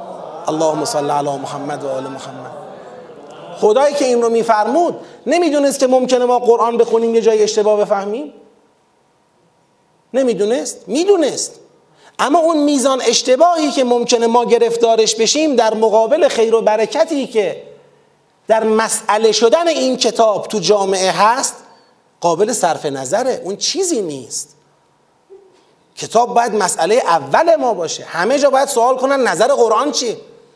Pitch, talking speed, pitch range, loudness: 235 Hz, 130 wpm, 215-290 Hz, -14 LUFS